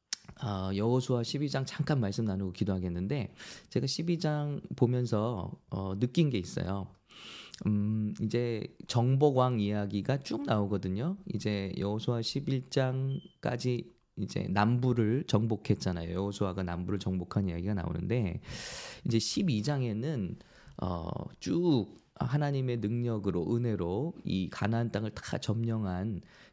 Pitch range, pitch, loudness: 100-125 Hz, 110 Hz, -32 LUFS